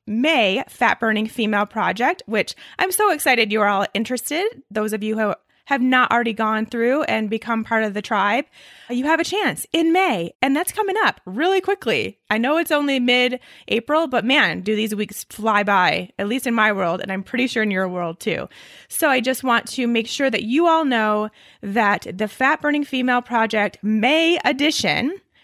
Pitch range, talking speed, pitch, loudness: 215-295 Hz, 200 wpm, 235 Hz, -20 LUFS